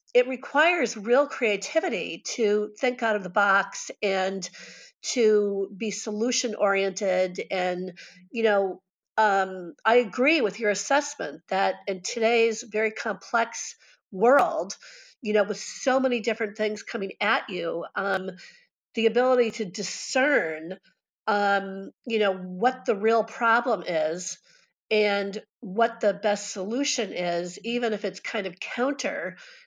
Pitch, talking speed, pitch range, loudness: 215 Hz, 130 wpm, 195-240 Hz, -25 LUFS